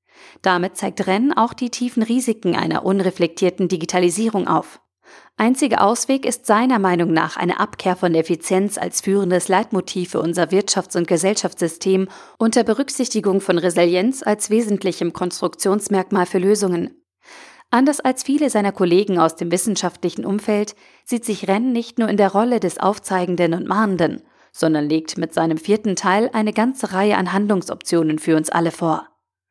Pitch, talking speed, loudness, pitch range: 195 Hz, 150 wpm, -19 LUFS, 180-215 Hz